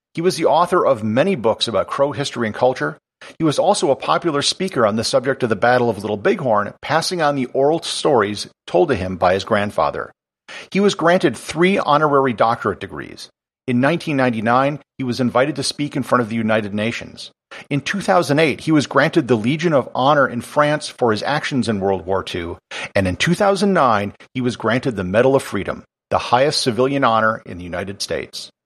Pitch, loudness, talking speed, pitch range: 130 Hz, -18 LUFS, 195 wpm, 110-150 Hz